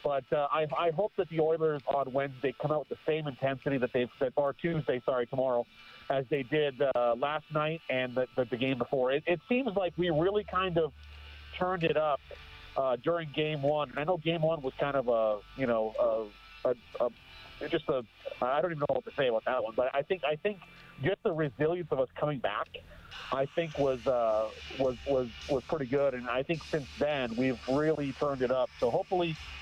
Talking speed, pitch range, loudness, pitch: 220 wpm, 130-160 Hz, -31 LUFS, 145 Hz